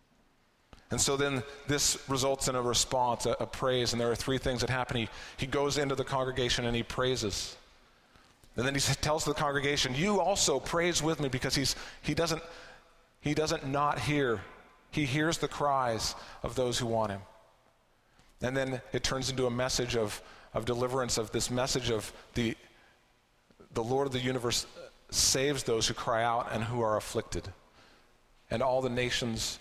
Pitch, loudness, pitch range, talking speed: 130 Hz, -31 LUFS, 115-140 Hz, 180 wpm